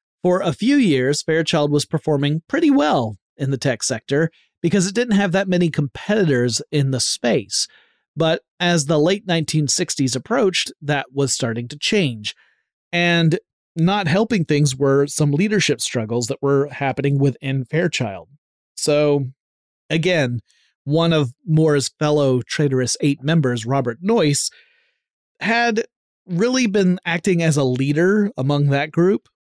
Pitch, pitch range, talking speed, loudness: 150 Hz, 140-175 Hz, 140 wpm, -19 LUFS